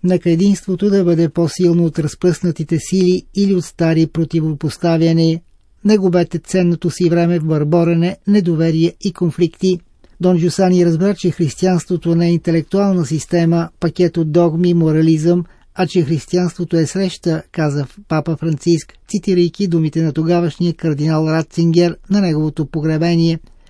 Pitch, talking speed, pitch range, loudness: 170 Hz, 130 wpm, 165-180 Hz, -16 LUFS